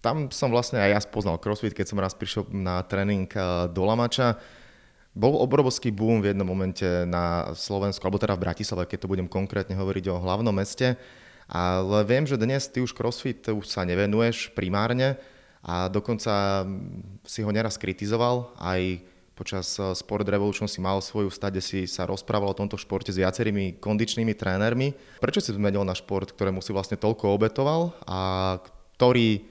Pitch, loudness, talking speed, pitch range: 100 Hz, -26 LUFS, 165 wpm, 95-115 Hz